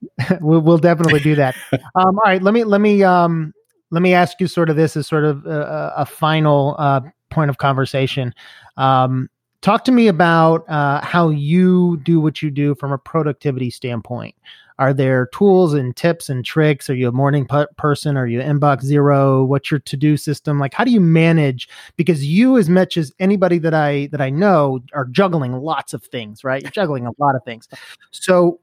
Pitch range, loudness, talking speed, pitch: 135-170 Hz, -16 LUFS, 200 wpm, 150 Hz